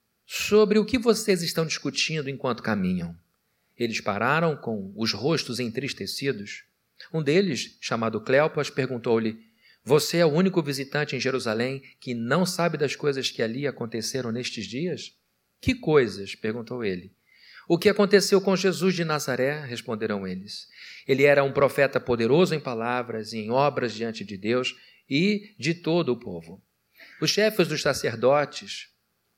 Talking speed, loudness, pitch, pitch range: 145 wpm, -25 LUFS, 130 Hz, 115-165 Hz